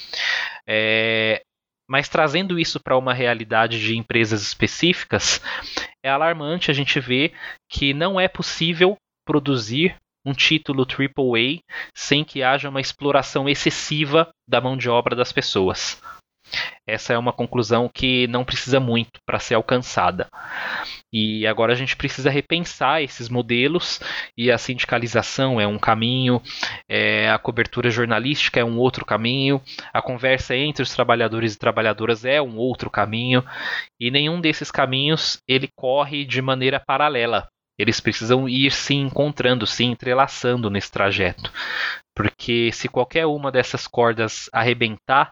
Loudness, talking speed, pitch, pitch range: -20 LUFS, 140 wpm, 125 Hz, 115-140 Hz